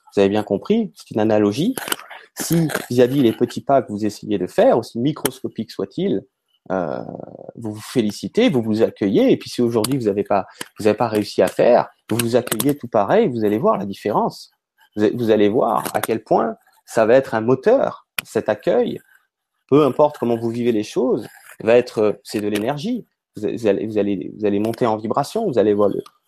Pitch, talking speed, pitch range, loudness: 115 Hz, 200 wpm, 105-135 Hz, -19 LUFS